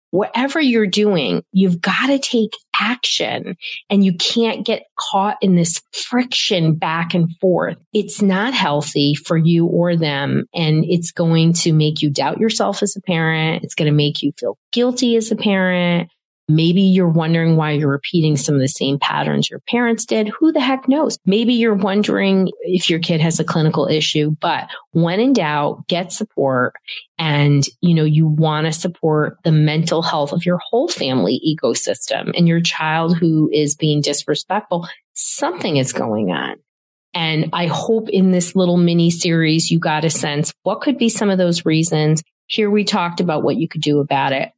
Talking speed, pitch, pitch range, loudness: 185 wpm, 170 Hz, 155-200 Hz, -17 LUFS